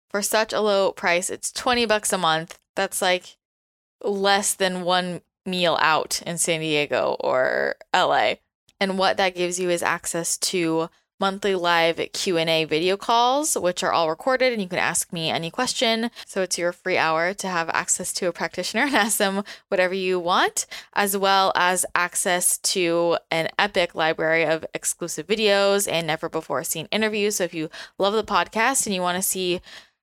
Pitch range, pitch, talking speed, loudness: 170-200 Hz, 185 Hz, 185 wpm, -22 LUFS